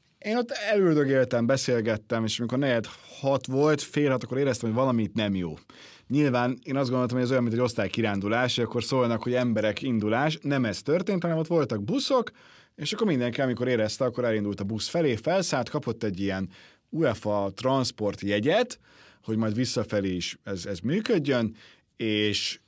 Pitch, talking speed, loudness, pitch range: 120 Hz, 170 wpm, -27 LUFS, 105-140 Hz